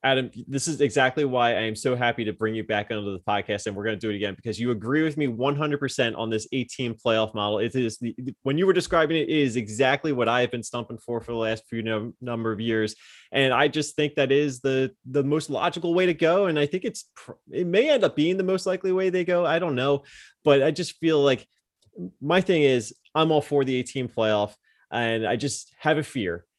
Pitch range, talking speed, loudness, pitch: 115-150 Hz, 250 wpm, -25 LUFS, 130 Hz